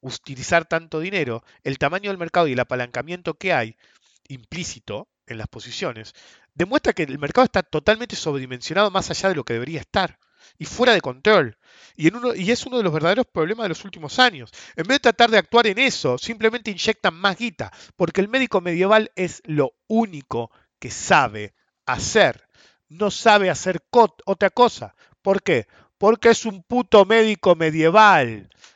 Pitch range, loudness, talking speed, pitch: 155-220 Hz, -20 LUFS, 175 wpm, 190 Hz